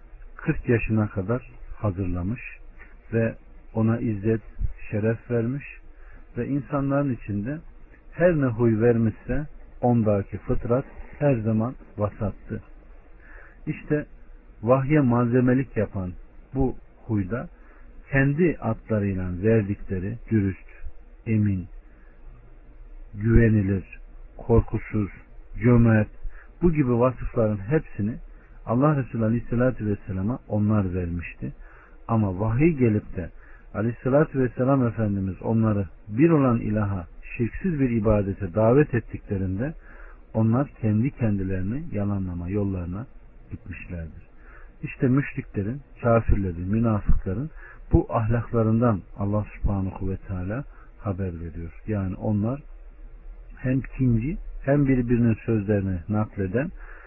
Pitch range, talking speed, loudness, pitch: 100-125 Hz, 90 wpm, -25 LUFS, 110 Hz